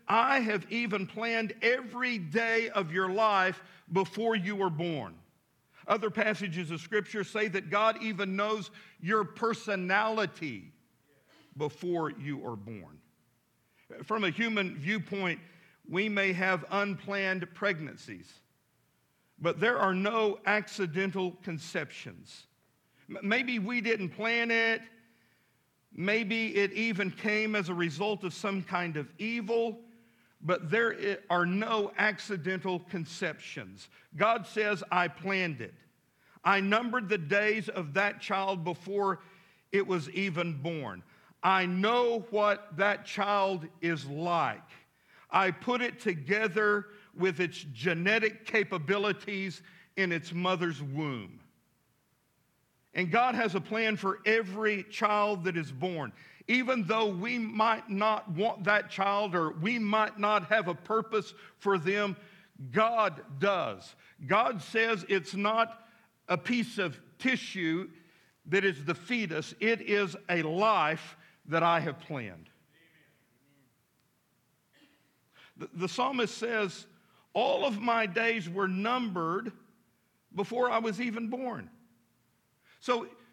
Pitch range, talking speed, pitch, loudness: 175-220 Hz, 120 wpm, 200 Hz, -30 LUFS